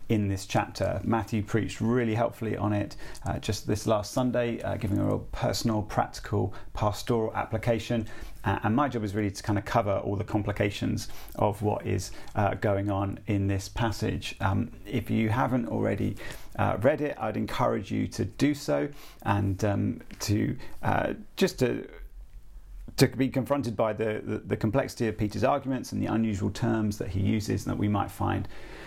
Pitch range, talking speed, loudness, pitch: 100-115 Hz, 180 wpm, -29 LUFS, 110 Hz